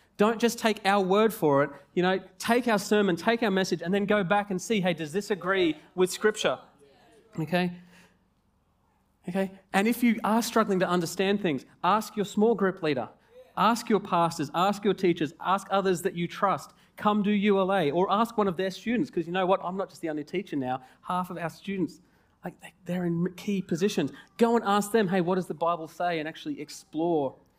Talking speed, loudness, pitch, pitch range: 205 wpm, -27 LUFS, 190 Hz, 175-210 Hz